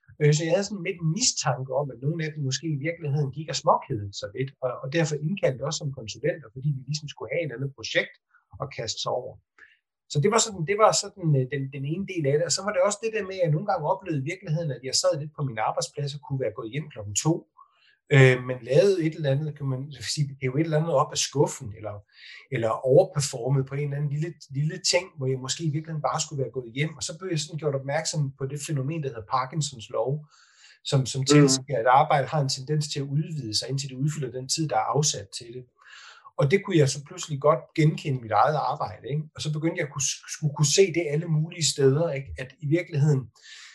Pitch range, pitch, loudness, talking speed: 135-160 Hz, 150 Hz, -26 LUFS, 245 wpm